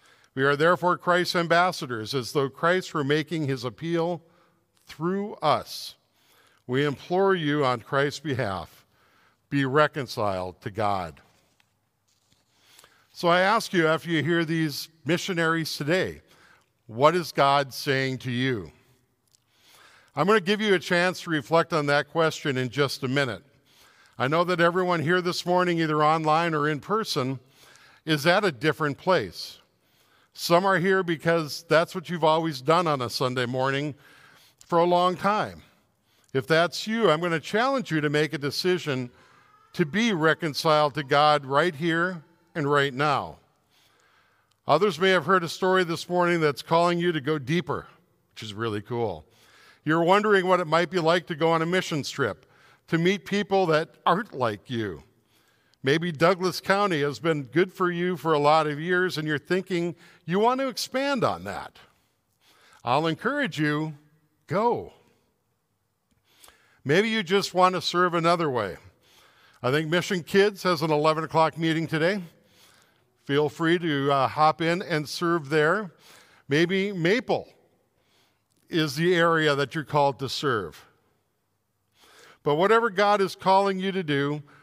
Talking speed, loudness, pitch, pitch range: 155 wpm, -24 LUFS, 160 Hz, 145-180 Hz